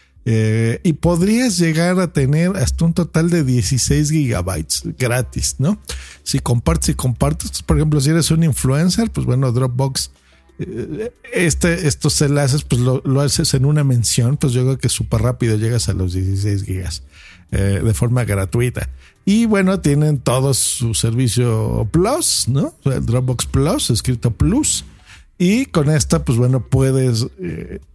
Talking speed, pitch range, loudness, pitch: 160 wpm, 115-150 Hz, -17 LUFS, 130 Hz